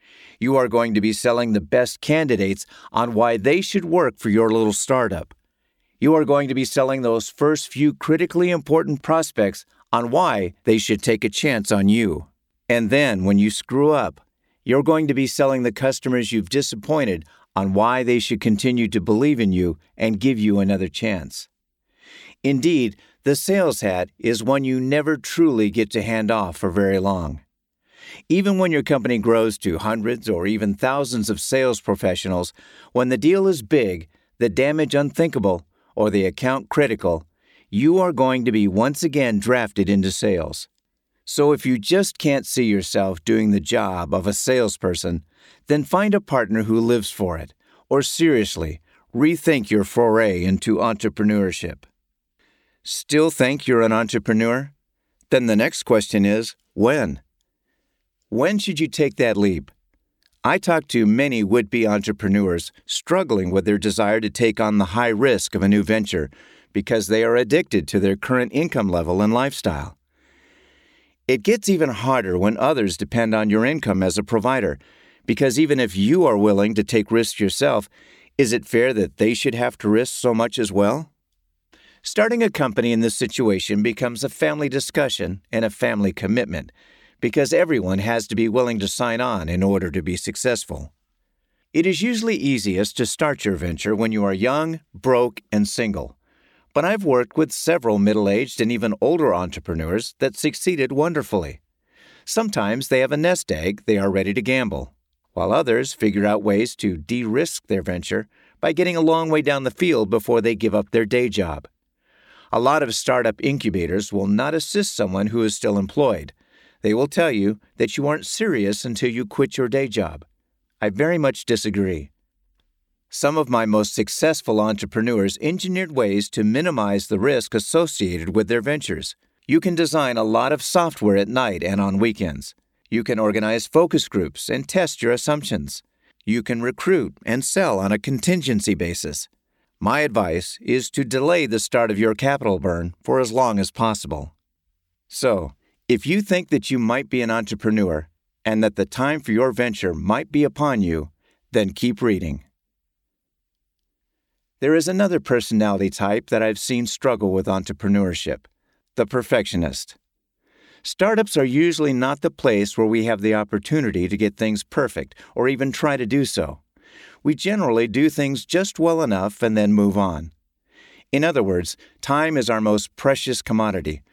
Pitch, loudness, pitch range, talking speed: 115 Hz, -20 LUFS, 100-135 Hz, 170 wpm